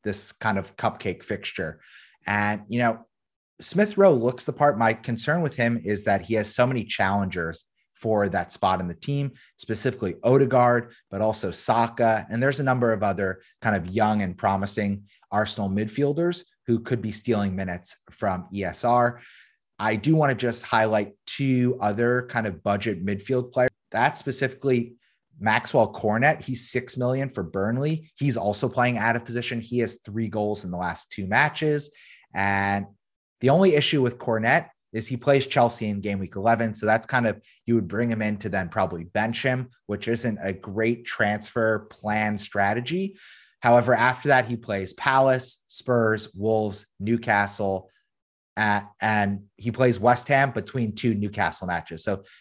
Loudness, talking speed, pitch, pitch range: -24 LUFS, 170 wpm, 115 Hz, 100-125 Hz